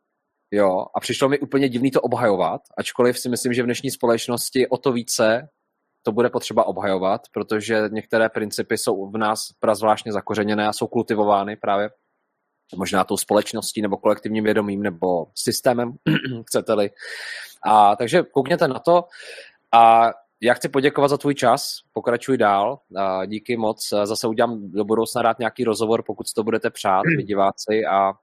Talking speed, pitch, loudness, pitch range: 160 wpm, 115 Hz, -21 LUFS, 105-125 Hz